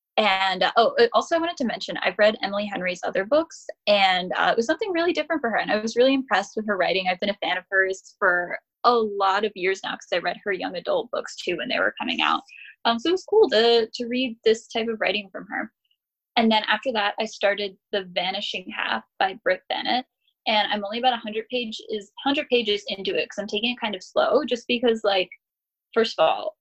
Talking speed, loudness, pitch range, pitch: 235 wpm, -23 LUFS, 200-245 Hz, 220 Hz